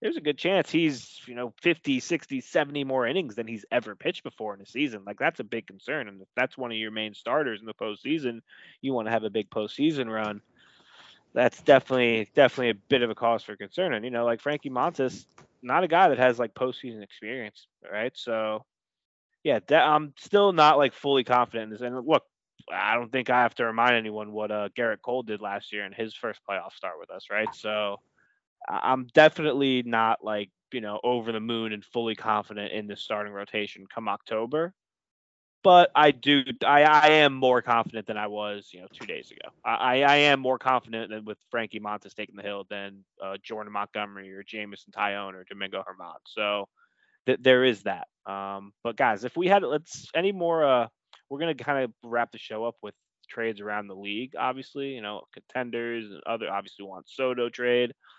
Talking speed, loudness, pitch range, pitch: 205 wpm, -26 LUFS, 105-130 Hz, 115 Hz